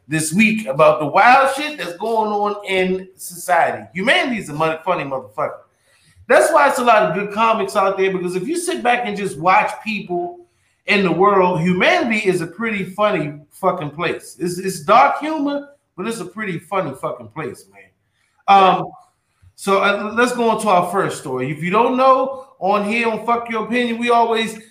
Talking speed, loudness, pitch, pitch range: 190 wpm, -17 LUFS, 195 Hz, 175-225 Hz